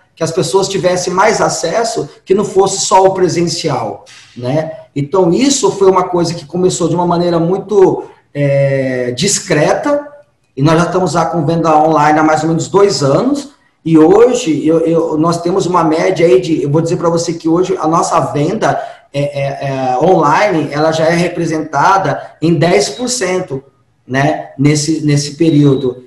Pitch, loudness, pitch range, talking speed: 165 Hz, -12 LUFS, 150-185 Hz, 170 wpm